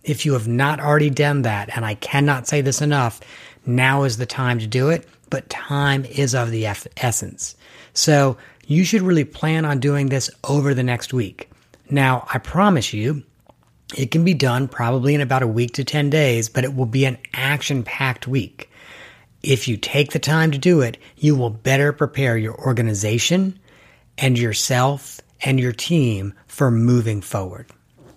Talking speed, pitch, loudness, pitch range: 180 wpm, 135 Hz, -19 LUFS, 120-145 Hz